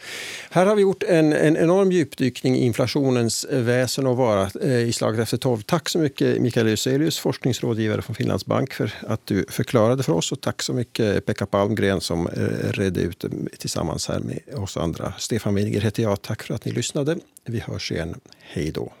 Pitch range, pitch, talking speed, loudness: 110-145 Hz, 125 Hz, 190 wpm, -22 LUFS